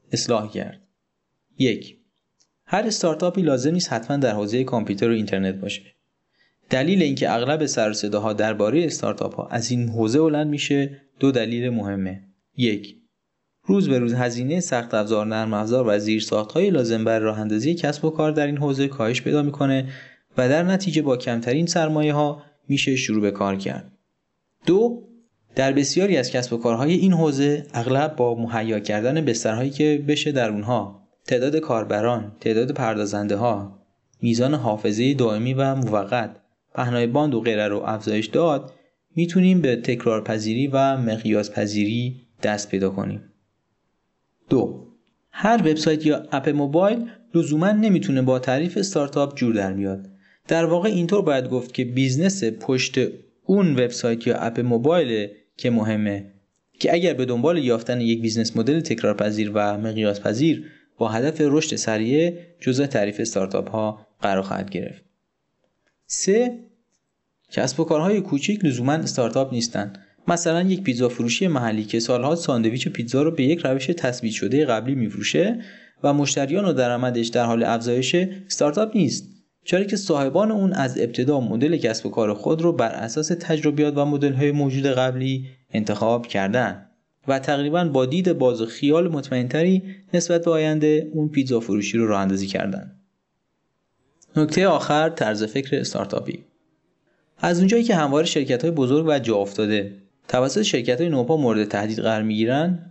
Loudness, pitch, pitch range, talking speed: -22 LUFS, 130 Hz, 110-155 Hz, 150 wpm